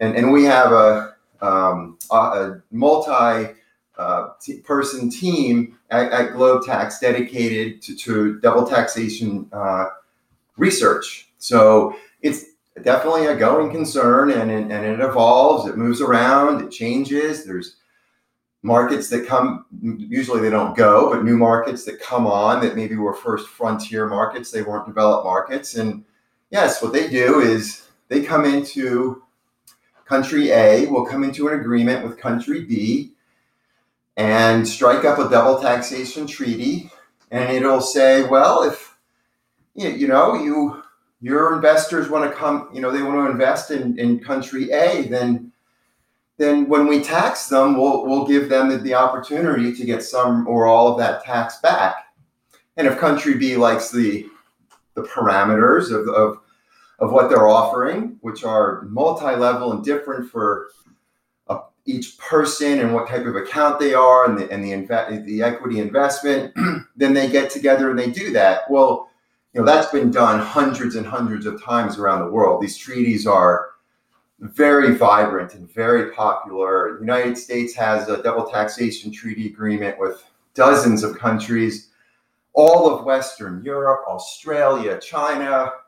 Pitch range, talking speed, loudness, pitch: 110-140 Hz, 150 wpm, -18 LUFS, 125 Hz